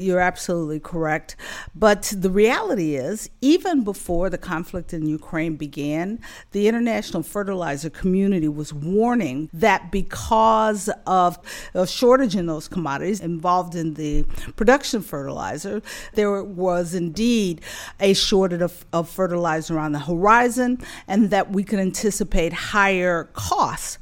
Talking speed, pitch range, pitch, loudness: 125 wpm, 165-210 Hz, 185 Hz, -21 LUFS